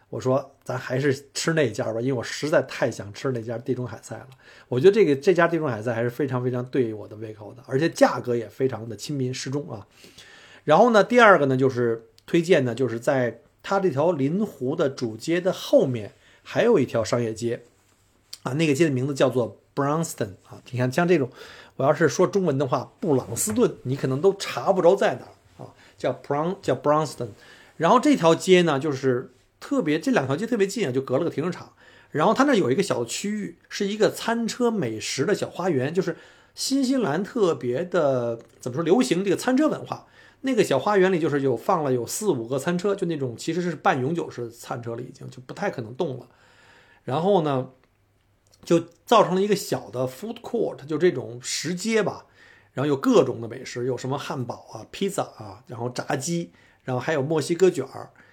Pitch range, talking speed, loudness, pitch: 120-175 Hz, 325 characters per minute, -23 LUFS, 135 Hz